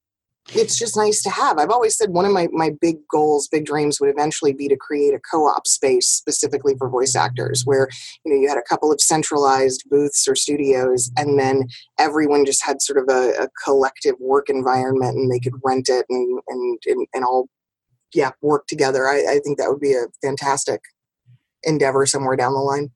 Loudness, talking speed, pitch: -18 LUFS, 205 wpm, 145 Hz